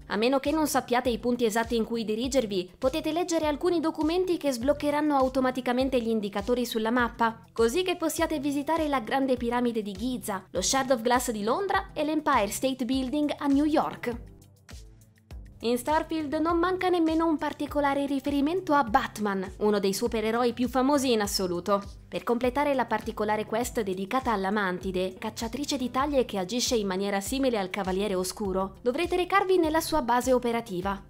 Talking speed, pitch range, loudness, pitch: 165 wpm, 215-290 Hz, -27 LUFS, 250 Hz